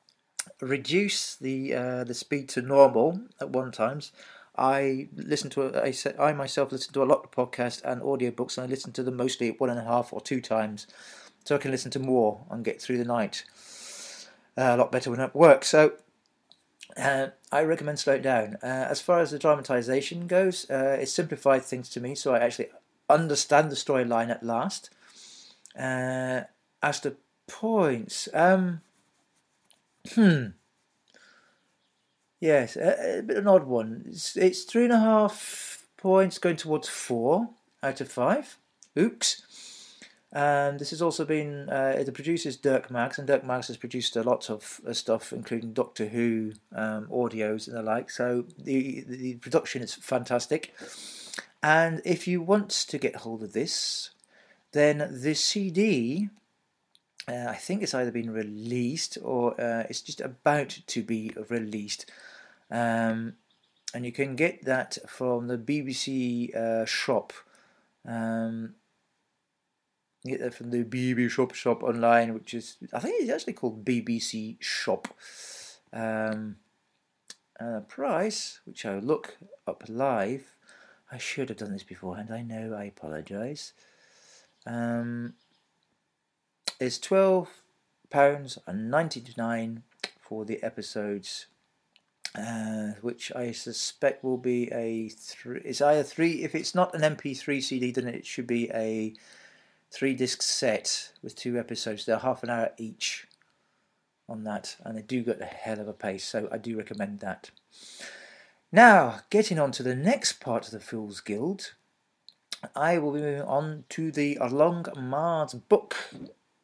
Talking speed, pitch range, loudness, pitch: 155 wpm, 115-150 Hz, -28 LUFS, 130 Hz